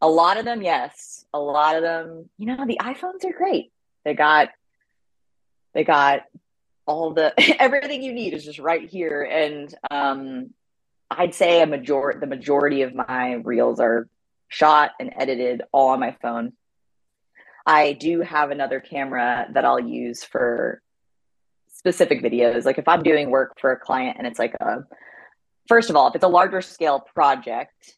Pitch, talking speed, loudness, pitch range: 150 Hz, 170 wpm, -20 LUFS, 135-175 Hz